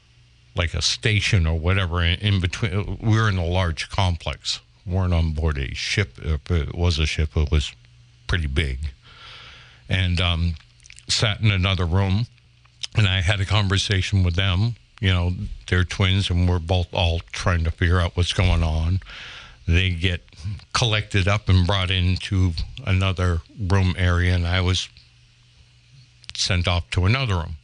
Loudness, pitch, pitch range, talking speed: -22 LUFS, 95 Hz, 85-105 Hz, 160 wpm